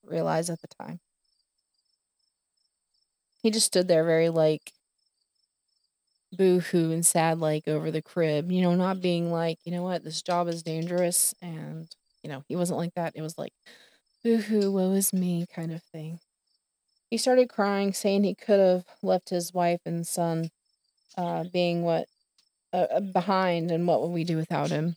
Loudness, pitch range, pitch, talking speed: -26 LUFS, 165-185 Hz, 170 Hz, 170 wpm